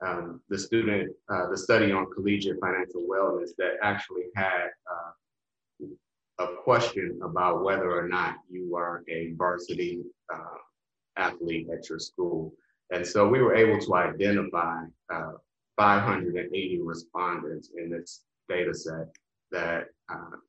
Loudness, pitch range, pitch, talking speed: -28 LUFS, 85-100 Hz, 90 Hz, 125 wpm